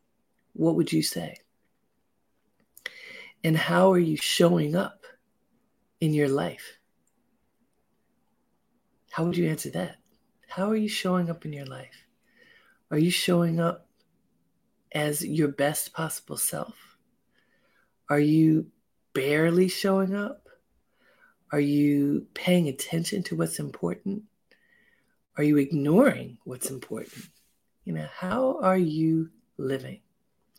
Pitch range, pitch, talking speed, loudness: 150-190 Hz, 170 Hz, 115 wpm, -26 LUFS